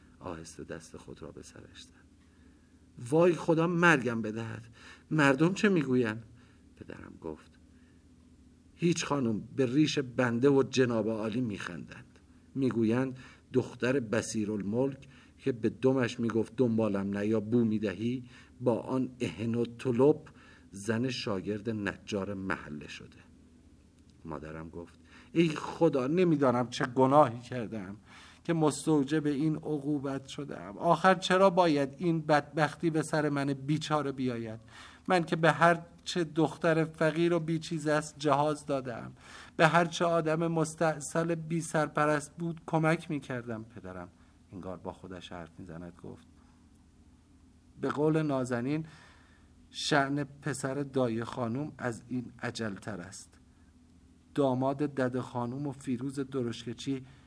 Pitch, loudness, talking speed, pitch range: 125 Hz, -30 LUFS, 120 wpm, 95-150 Hz